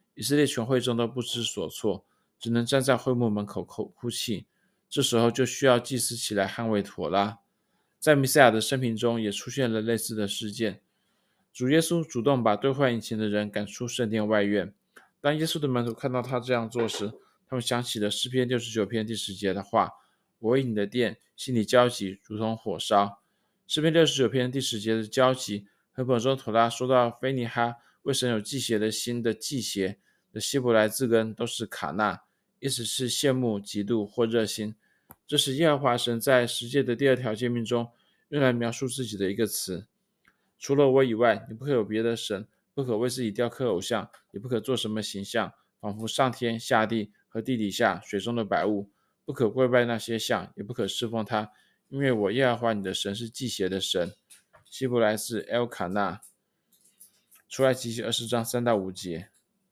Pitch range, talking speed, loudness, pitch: 110-130 Hz, 280 characters per minute, -27 LUFS, 115 Hz